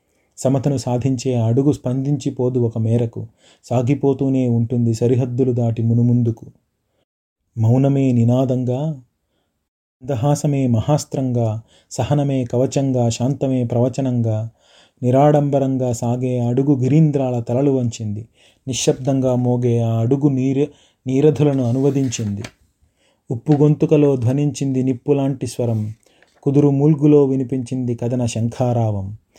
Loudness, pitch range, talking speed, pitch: -18 LUFS, 120-140 Hz, 90 wpm, 130 Hz